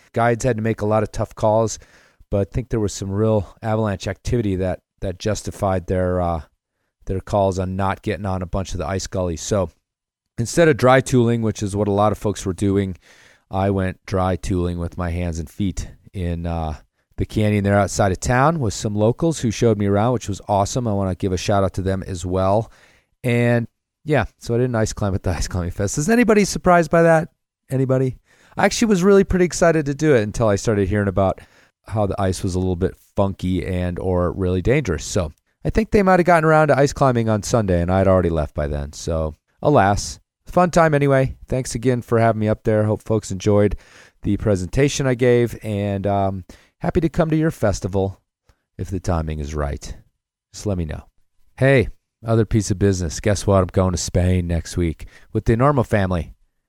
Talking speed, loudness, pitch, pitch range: 215 wpm, -20 LUFS, 100 Hz, 95-120 Hz